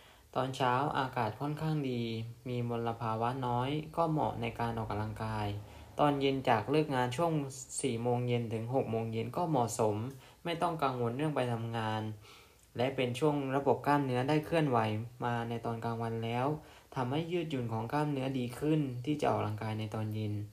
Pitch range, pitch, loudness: 115-140 Hz, 120 Hz, -34 LUFS